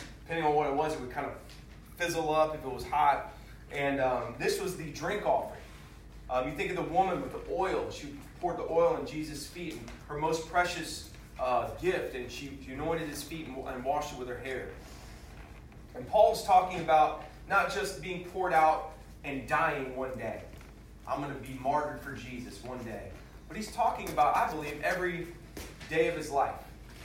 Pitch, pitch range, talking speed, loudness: 150 Hz, 130-165 Hz, 200 wpm, -32 LUFS